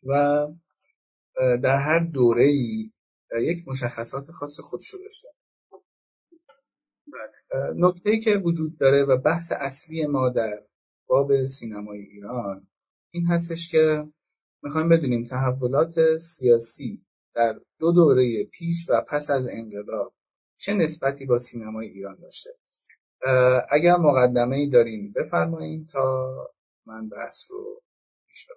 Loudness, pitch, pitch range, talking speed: -23 LUFS, 135 Hz, 120-165 Hz, 110 wpm